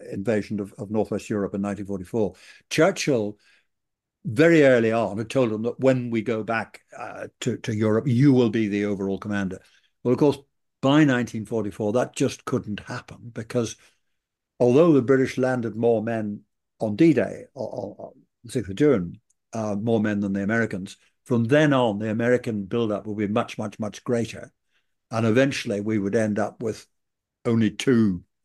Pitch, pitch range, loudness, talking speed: 115 Hz, 105-125 Hz, -23 LUFS, 170 wpm